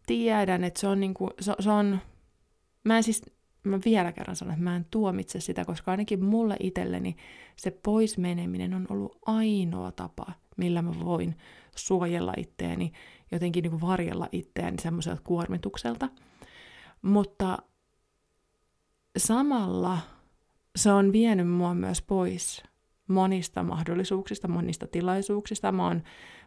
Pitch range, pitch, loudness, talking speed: 165-200 Hz, 185 Hz, -29 LUFS, 130 wpm